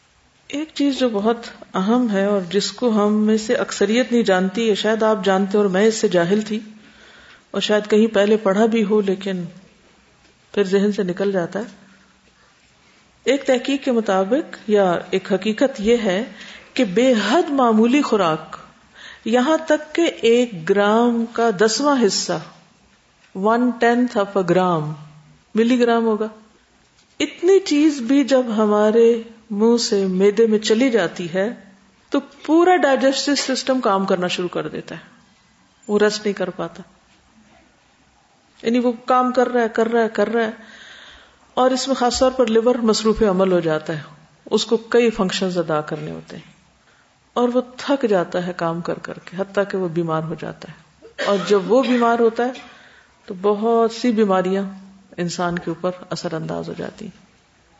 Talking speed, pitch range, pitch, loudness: 165 wpm, 190-240 Hz, 215 Hz, -19 LUFS